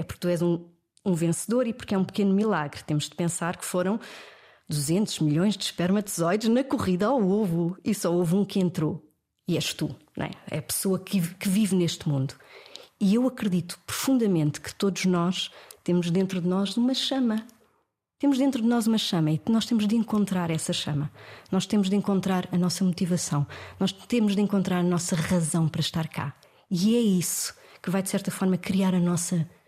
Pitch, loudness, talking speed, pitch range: 185 Hz, -26 LUFS, 200 wpm, 170-210 Hz